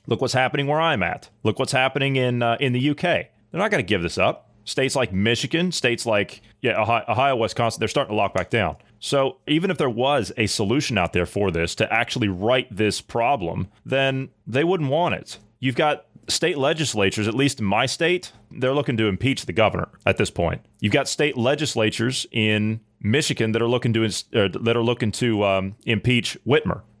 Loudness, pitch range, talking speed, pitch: -22 LUFS, 110-135 Hz, 205 wpm, 115 Hz